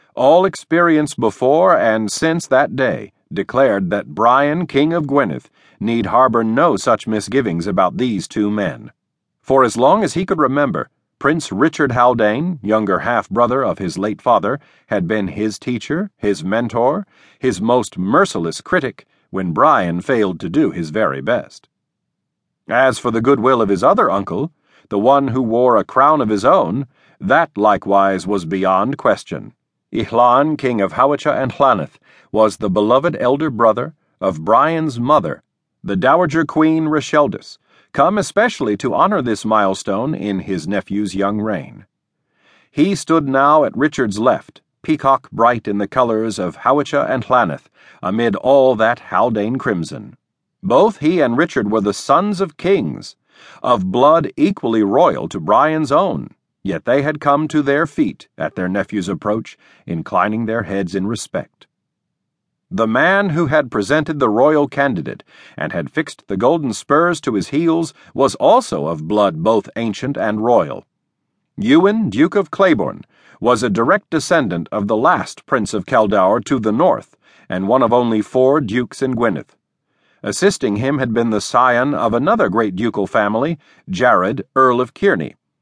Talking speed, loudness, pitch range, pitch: 160 wpm, -16 LUFS, 105-155 Hz, 130 Hz